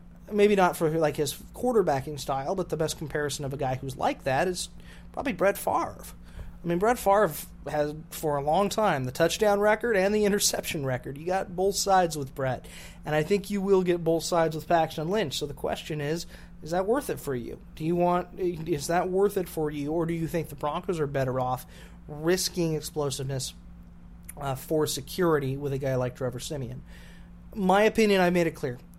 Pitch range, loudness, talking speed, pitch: 145-185 Hz, -27 LUFS, 205 wpm, 160 Hz